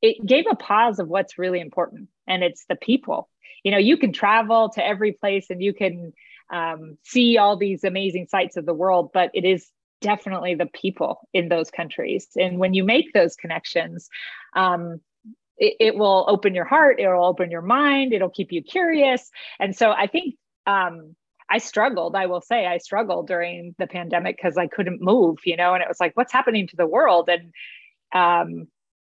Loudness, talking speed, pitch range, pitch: -21 LUFS, 195 wpm, 175-220 Hz, 190 Hz